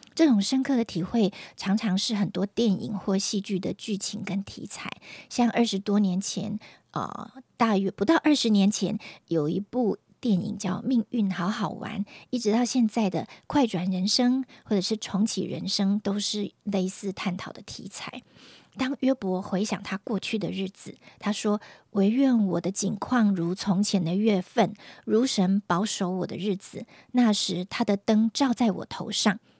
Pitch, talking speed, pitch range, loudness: 205 Hz, 240 characters per minute, 195-225 Hz, -26 LUFS